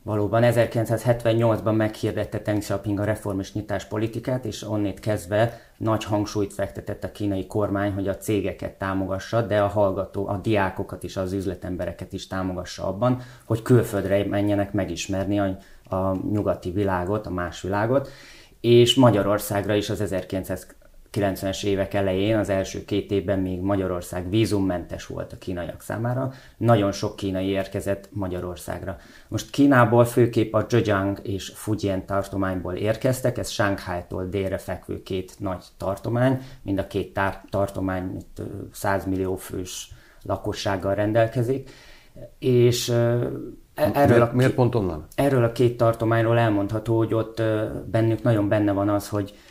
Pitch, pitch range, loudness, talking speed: 100 Hz, 95-115 Hz, -24 LUFS, 130 wpm